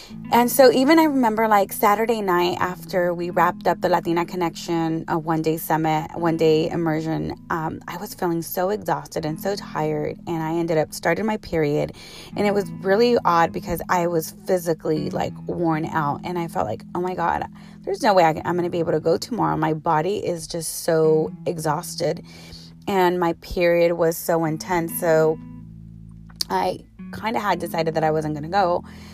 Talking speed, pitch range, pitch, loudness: 190 wpm, 160-185 Hz, 170 Hz, -22 LUFS